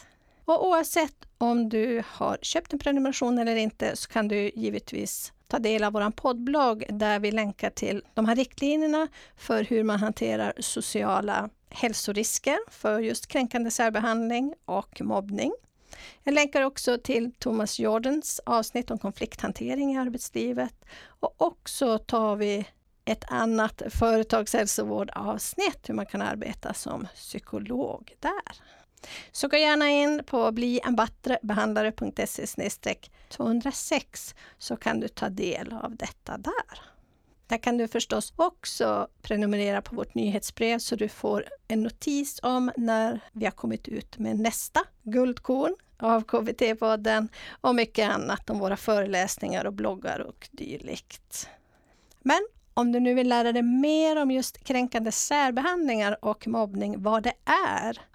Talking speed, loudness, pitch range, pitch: 135 wpm, -27 LUFS, 220-265 Hz, 235 Hz